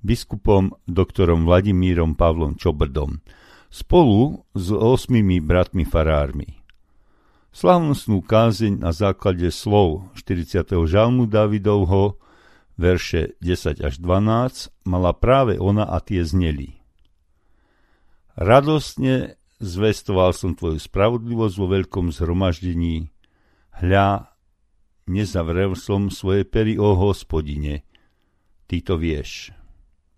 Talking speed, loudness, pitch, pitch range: 90 wpm, -20 LUFS, 95 Hz, 85-105 Hz